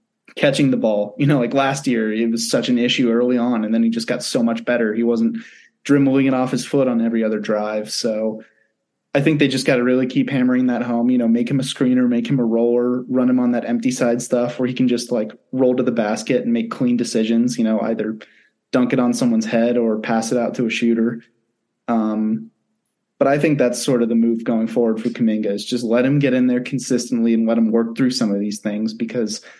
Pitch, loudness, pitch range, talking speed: 120 Hz, -19 LUFS, 115-125 Hz, 245 wpm